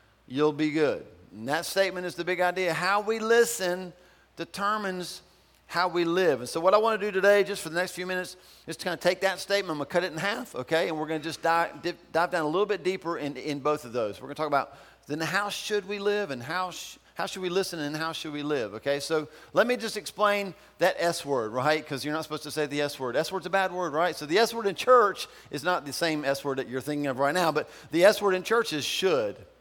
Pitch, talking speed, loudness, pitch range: 175 Hz, 280 wpm, -27 LUFS, 150-195 Hz